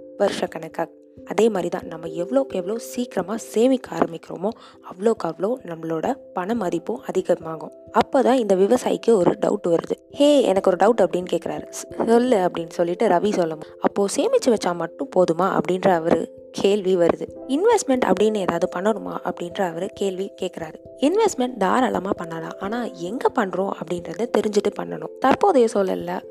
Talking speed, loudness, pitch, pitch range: 135 wpm, -22 LUFS, 195 Hz, 175-235 Hz